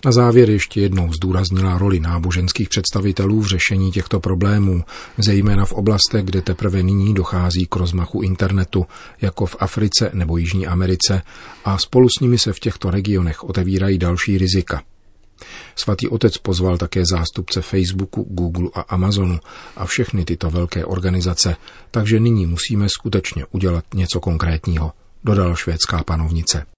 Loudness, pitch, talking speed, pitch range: -18 LUFS, 95 Hz, 140 wpm, 90-100 Hz